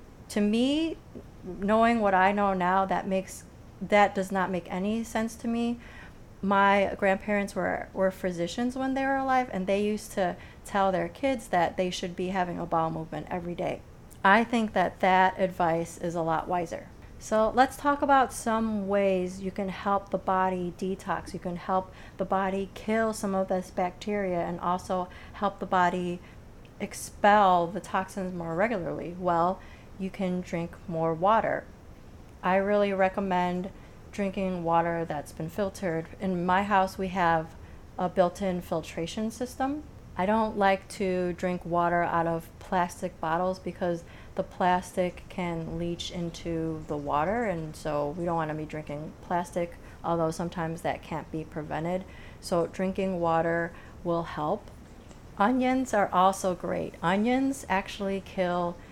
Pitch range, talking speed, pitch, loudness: 175-200 Hz, 155 wpm, 185 Hz, -28 LUFS